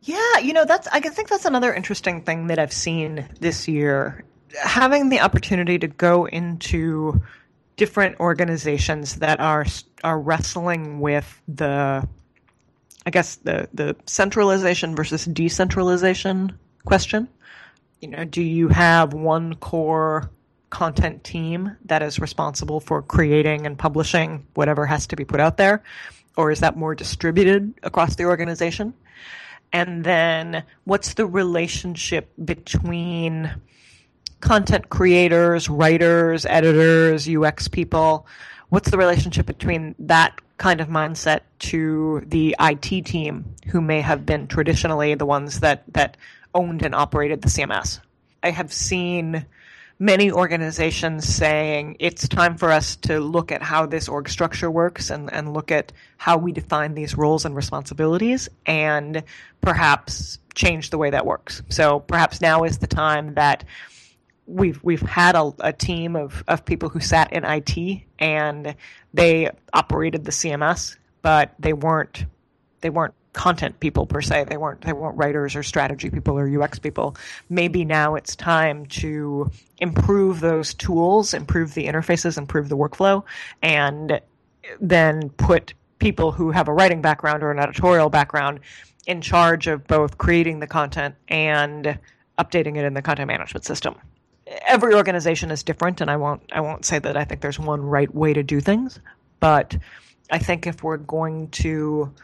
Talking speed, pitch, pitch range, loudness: 150 wpm, 160 Hz, 150-170 Hz, -20 LUFS